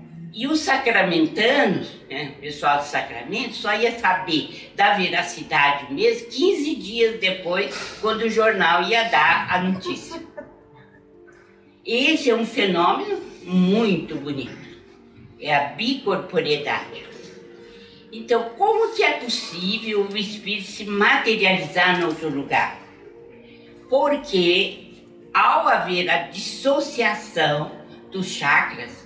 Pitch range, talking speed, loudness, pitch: 175-240 Hz, 105 wpm, -21 LUFS, 210 Hz